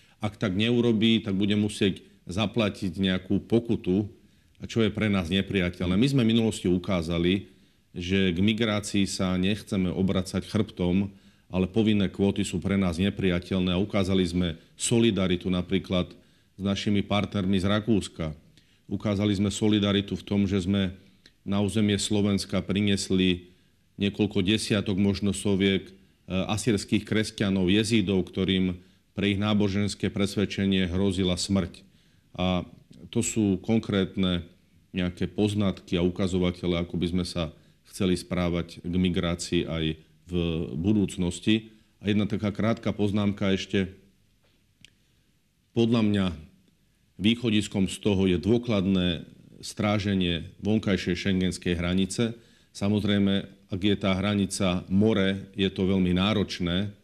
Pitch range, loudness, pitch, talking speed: 90-105 Hz, -26 LUFS, 95 Hz, 120 wpm